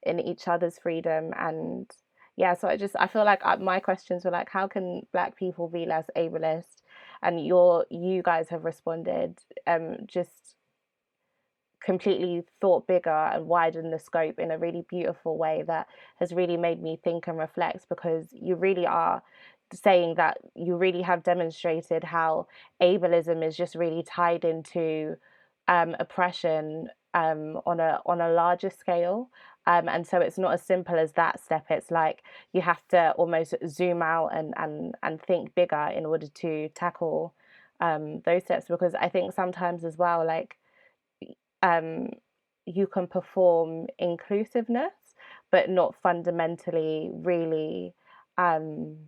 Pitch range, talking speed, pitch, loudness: 165-180 Hz, 150 wpm, 170 Hz, -27 LUFS